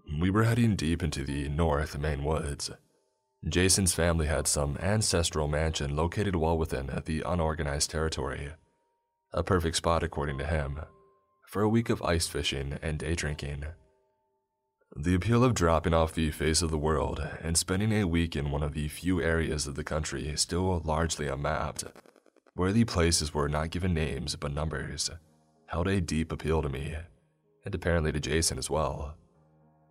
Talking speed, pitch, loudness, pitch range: 165 wpm, 80 Hz, -29 LUFS, 75-90 Hz